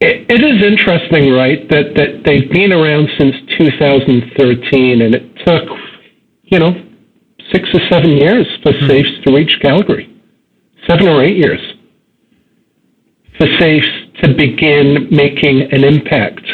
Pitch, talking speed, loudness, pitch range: 150 Hz, 135 wpm, -10 LUFS, 140-175 Hz